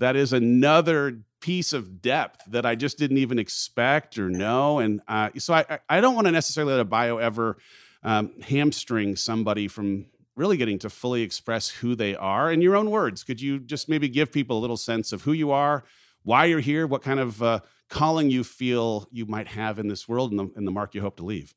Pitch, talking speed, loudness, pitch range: 120 Hz, 225 wpm, -24 LUFS, 110-145 Hz